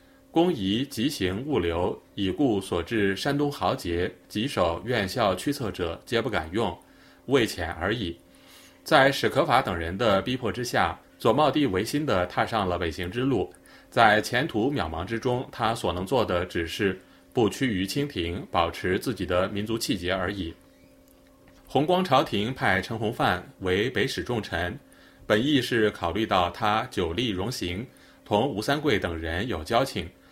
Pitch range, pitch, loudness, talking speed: 90-130 Hz, 105 Hz, -26 LUFS, 230 characters per minute